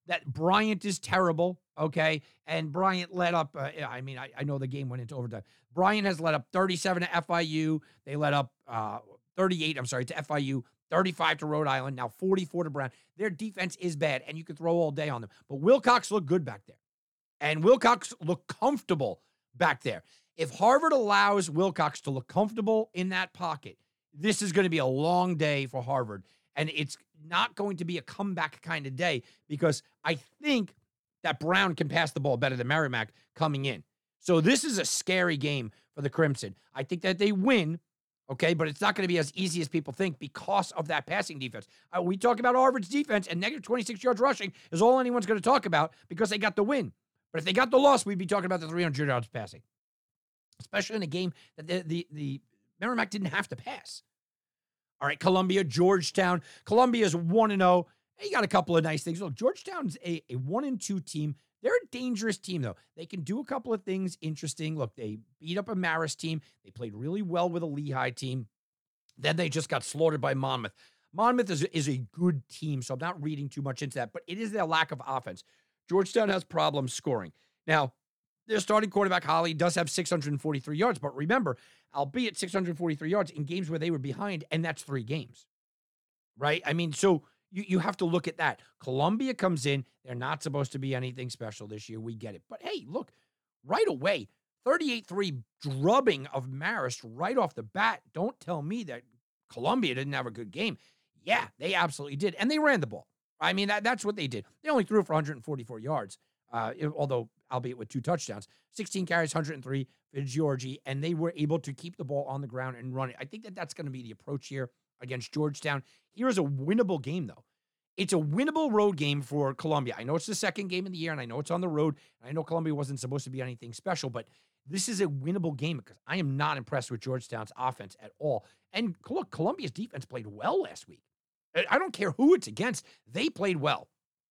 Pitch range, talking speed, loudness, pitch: 135-190 Hz, 215 wpm, -30 LUFS, 160 Hz